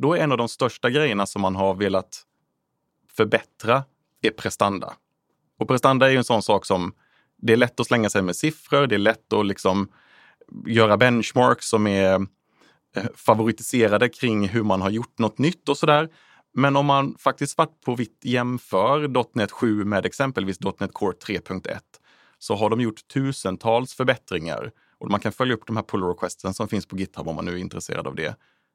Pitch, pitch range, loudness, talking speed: 115 Hz, 100-135 Hz, -22 LUFS, 190 wpm